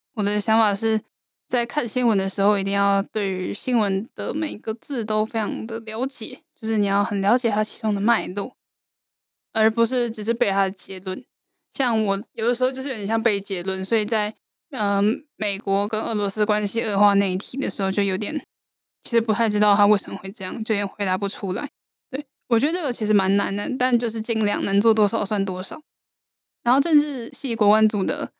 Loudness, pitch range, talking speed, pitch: -23 LUFS, 200-235 Hz, 300 characters per minute, 215 Hz